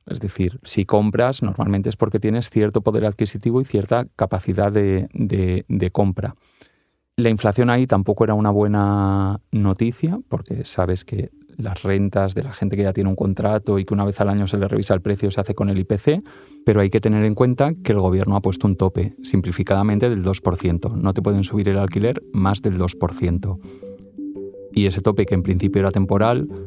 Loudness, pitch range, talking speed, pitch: -20 LUFS, 95-110 Hz, 200 wpm, 100 Hz